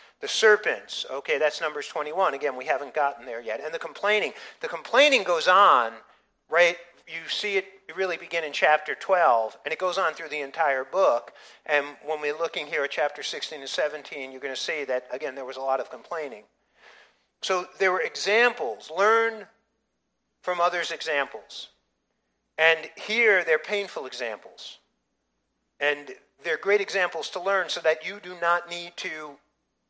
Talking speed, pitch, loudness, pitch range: 170 wpm, 175 Hz, -25 LUFS, 155-205 Hz